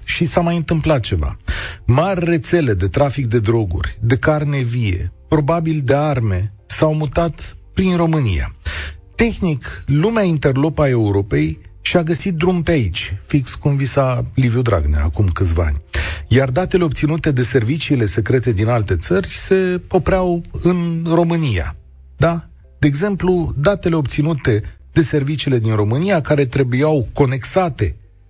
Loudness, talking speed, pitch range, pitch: -17 LUFS, 135 wpm, 100-165 Hz, 135 Hz